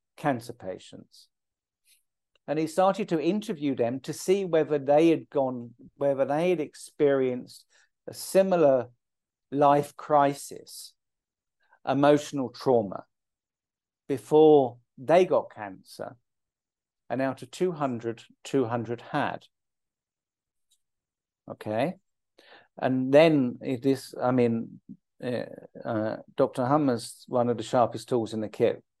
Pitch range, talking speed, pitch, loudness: 120-150 Hz, 105 wpm, 135 Hz, -26 LUFS